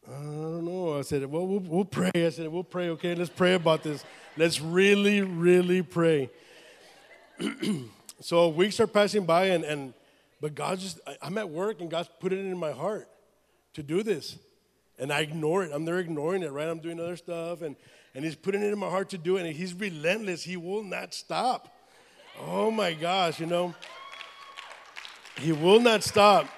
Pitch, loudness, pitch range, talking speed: 175 Hz, -27 LUFS, 160-190 Hz, 195 wpm